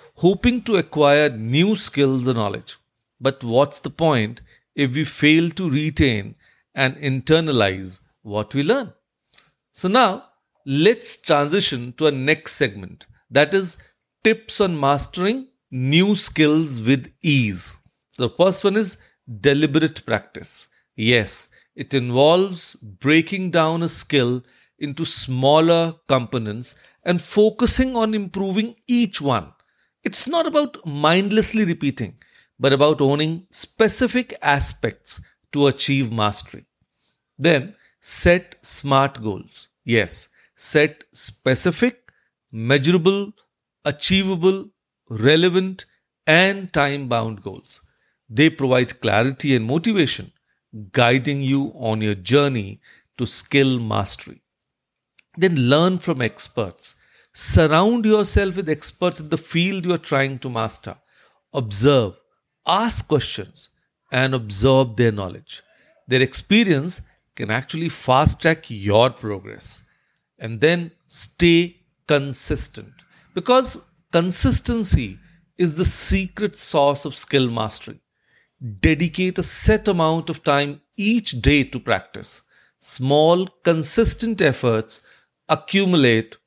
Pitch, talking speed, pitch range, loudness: 145 Hz, 110 wpm, 125-180 Hz, -19 LUFS